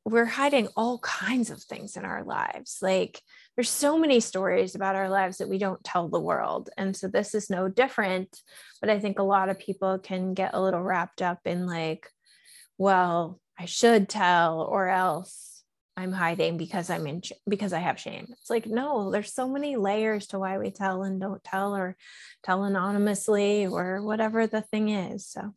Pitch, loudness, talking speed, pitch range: 195 Hz, -27 LUFS, 190 wpm, 185-220 Hz